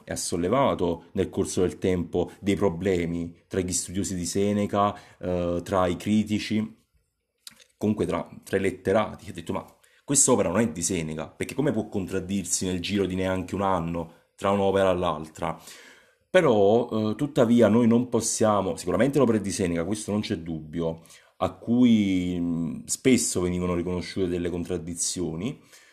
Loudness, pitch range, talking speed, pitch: -25 LUFS, 85-105 Hz, 155 wpm, 95 Hz